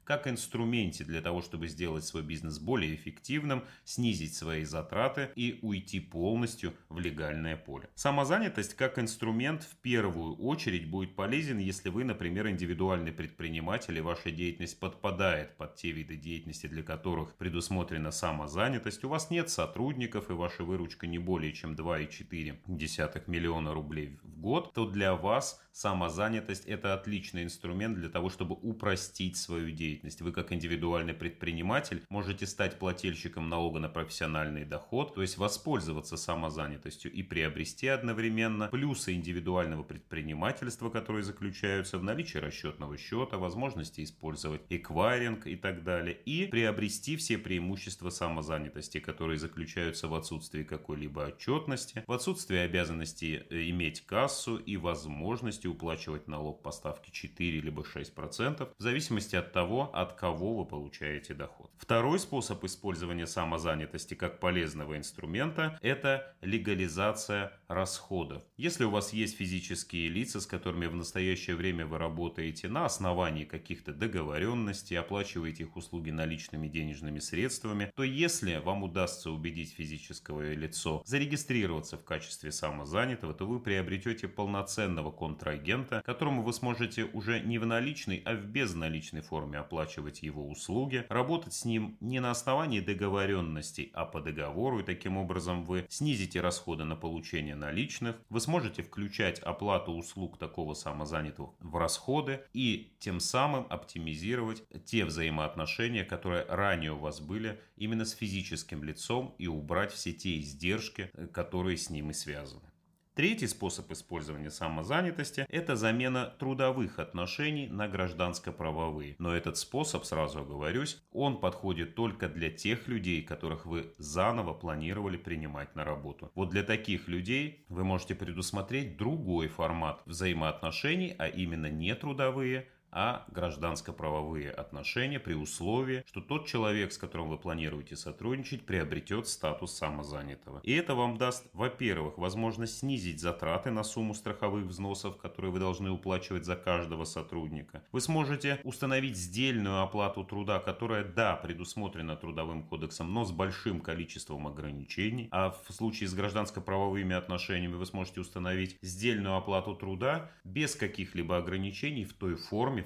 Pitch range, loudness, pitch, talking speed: 80-110 Hz, -35 LUFS, 90 Hz, 135 wpm